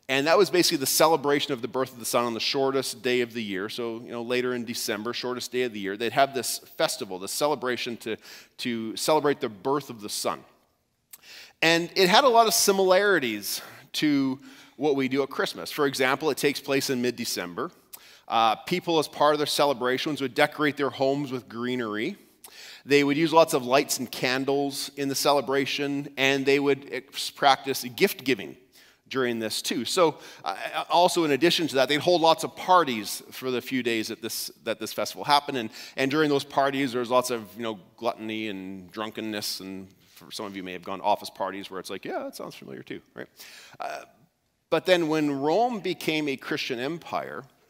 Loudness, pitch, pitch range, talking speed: -25 LUFS, 135 Hz, 120-150 Hz, 205 wpm